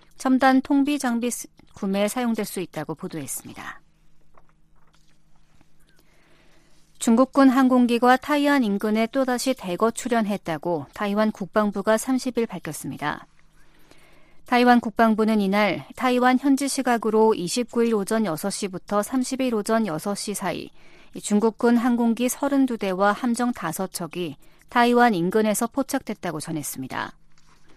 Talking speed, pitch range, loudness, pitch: 255 characters per minute, 185-250 Hz, -22 LUFS, 220 Hz